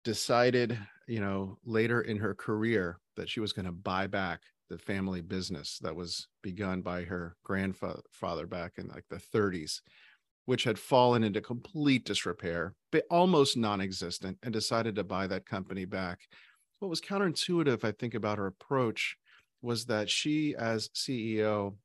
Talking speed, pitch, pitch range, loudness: 155 wpm, 105 Hz, 95-120 Hz, -32 LUFS